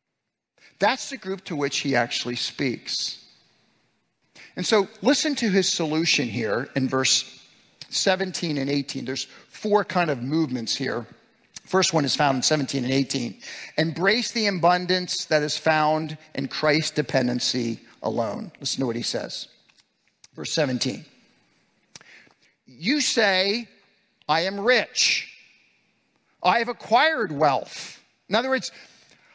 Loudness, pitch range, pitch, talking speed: -23 LUFS, 135-195 Hz, 160 Hz, 130 wpm